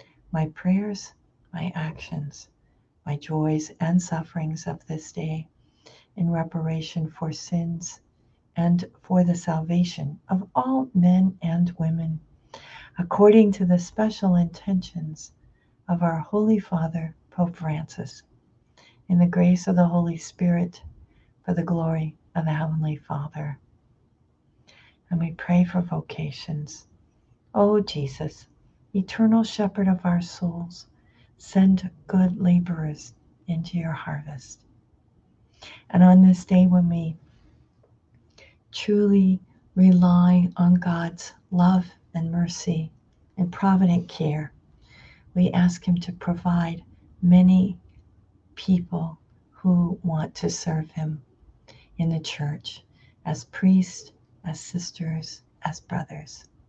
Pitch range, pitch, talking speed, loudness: 155-180 Hz, 170 Hz, 110 wpm, -23 LUFS